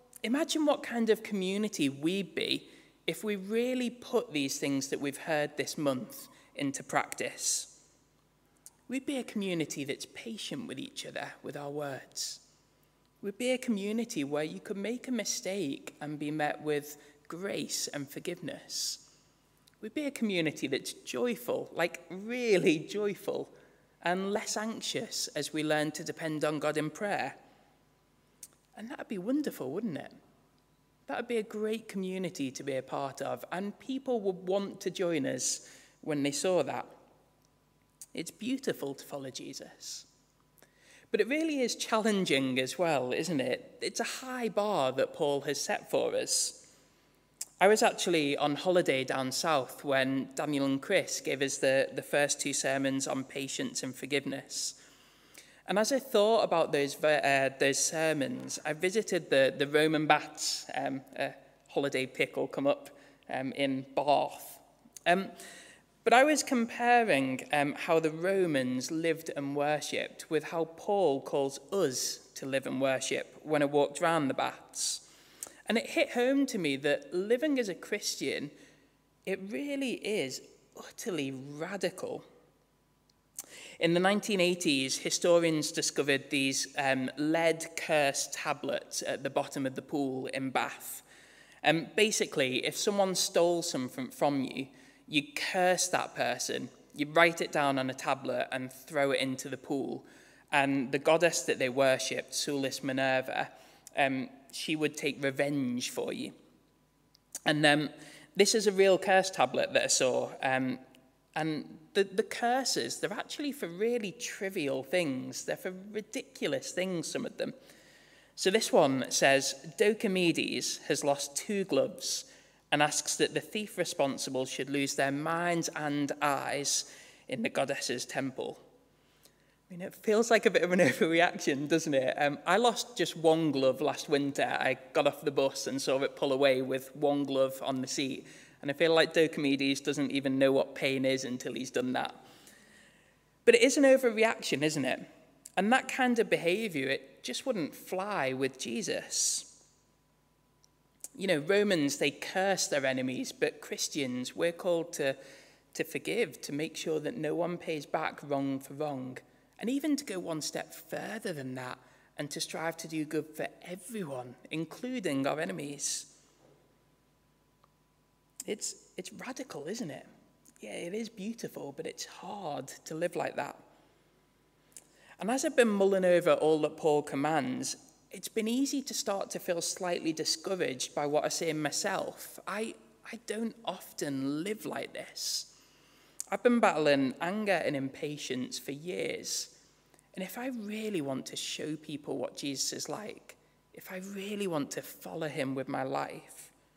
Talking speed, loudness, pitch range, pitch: 160 wpm, -31 LUFS, 140-205 Hz, 160 Hz